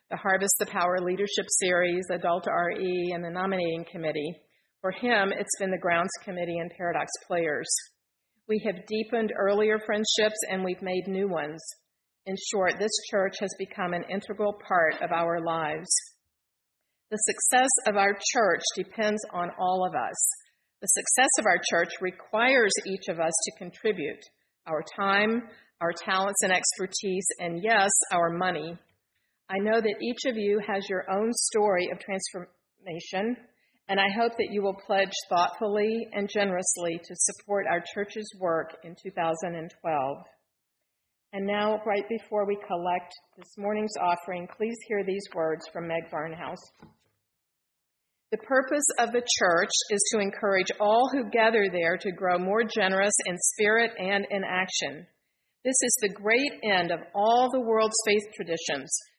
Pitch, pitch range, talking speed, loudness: 195 Hz, 180-215 Hz, 155 wpm, -27 LUFS